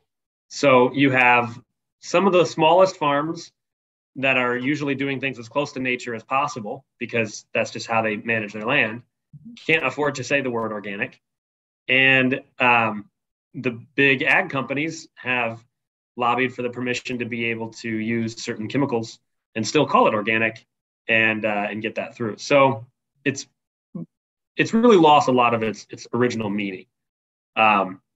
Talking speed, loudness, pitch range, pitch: 160 wpm, -21 LUFS, 115-140 Hz, 125 Hz